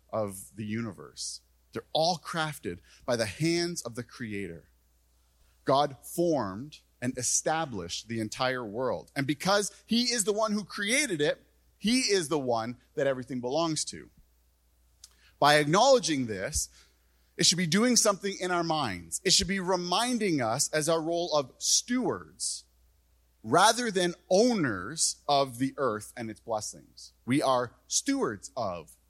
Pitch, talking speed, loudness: 135 Hz, 145 wpm, -28 LUFS